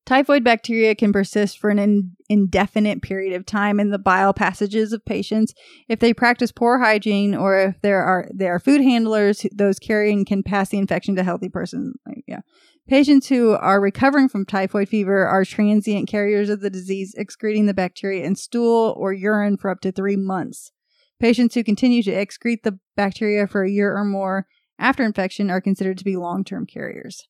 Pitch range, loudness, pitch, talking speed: 195-230 Hz, -19 LUFS, 205 Hz, 185 wpm